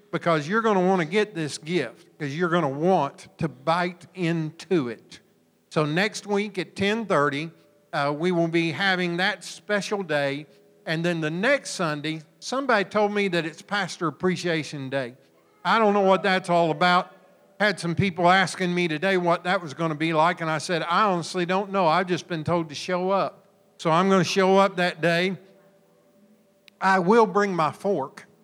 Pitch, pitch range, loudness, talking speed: 180 Hz, 165-195 Hz, -24 LUFS, 190 wpm